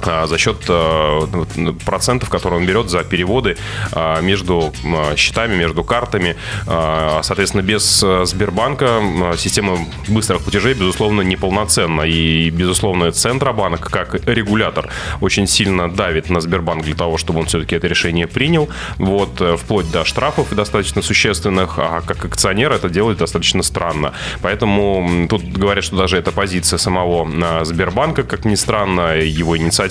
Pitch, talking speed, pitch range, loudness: 90 Hz, 130 wpm, 85-100 Hz, -16 LUFS